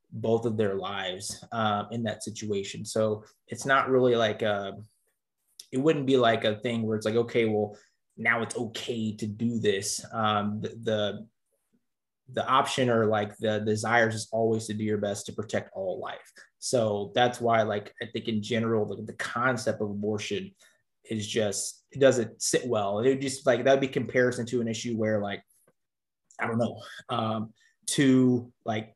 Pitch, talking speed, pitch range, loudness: 110 Hz, 180 wpm, 105-120 Hz, -28 LUFS